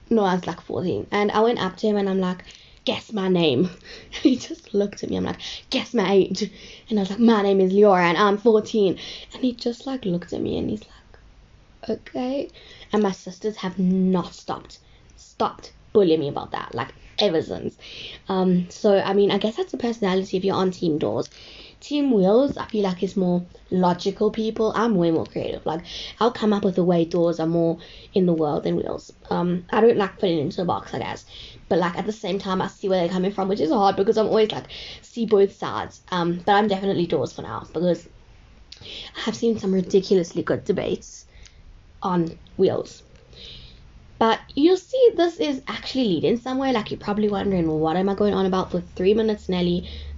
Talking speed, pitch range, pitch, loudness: 215 wpm, 175-215 Hz, 195 Hz, -22 LUFS